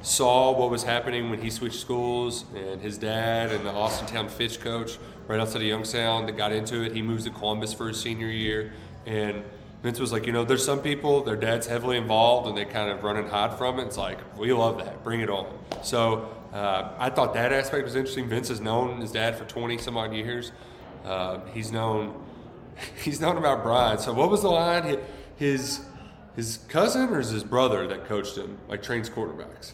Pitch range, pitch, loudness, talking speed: 110-120 Hz, 115 Hz, -27 LUFS, 215 wpm